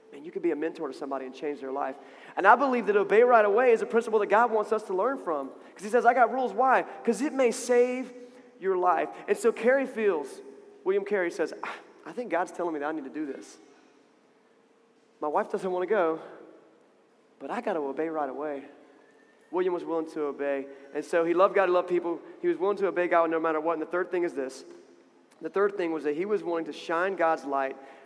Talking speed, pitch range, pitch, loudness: 240 wpm, 160-240 Hz, 190 Hz, -27 LUFS